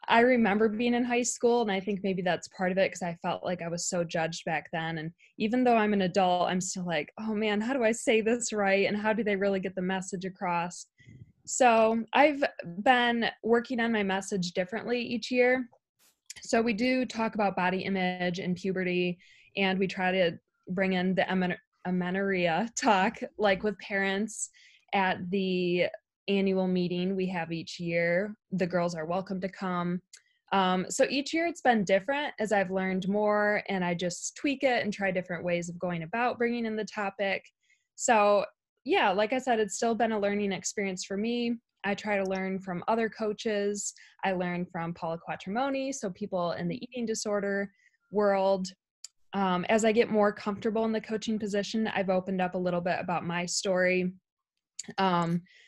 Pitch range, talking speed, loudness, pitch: 180-225 Hz, 190 wpm, -29 LUFS, 195 Hz